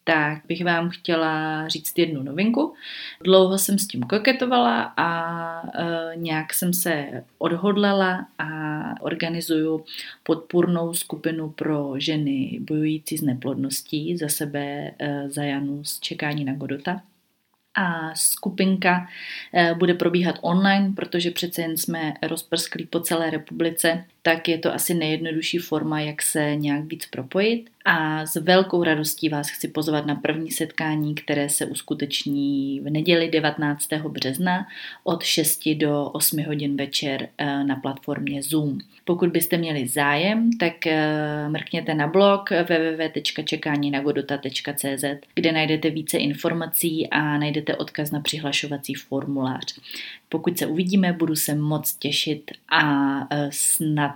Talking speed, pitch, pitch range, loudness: 125 wpm, 155 Hz, 145-170 Hz, -23 LUFS